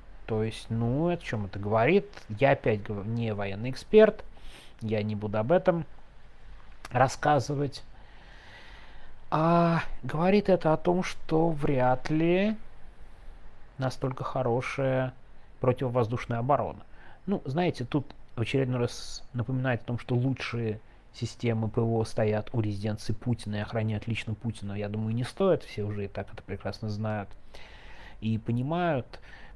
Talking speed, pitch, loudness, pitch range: 130 wpm, 120 Hz, -29 LUFS, 110-140 Hz